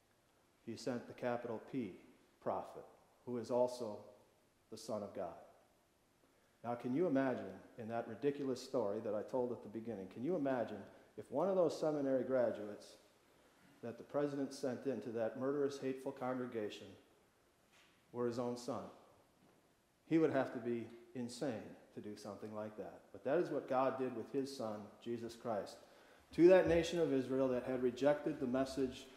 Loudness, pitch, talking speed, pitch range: -40 LUFS, 125 Hz, 165 wpm, 115-135 Hz